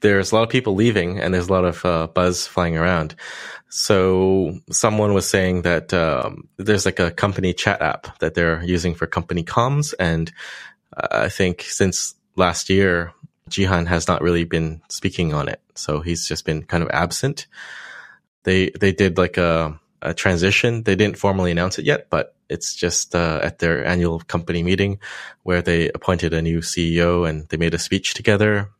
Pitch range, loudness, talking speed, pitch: 85-95 Hz, -20 LUFS, 185 wpm, 90 Hz